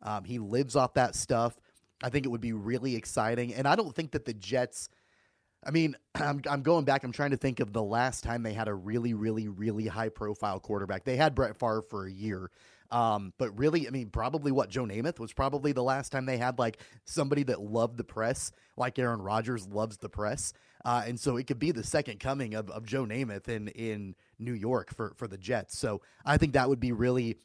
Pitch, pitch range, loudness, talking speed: 120 Hz, 110-135 Hz, -32 LUFS, 230 wpm